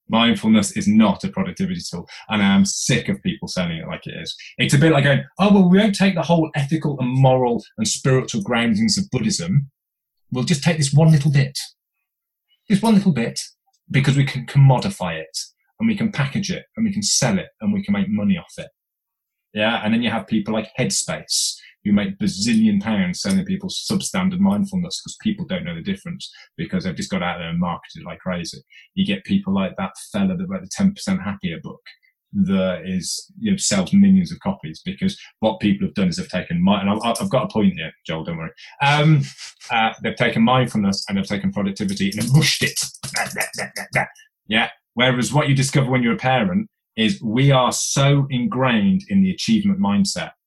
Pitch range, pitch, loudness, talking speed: 135-195 Hz, 185 Hz, -20 LUFS, 205 wpm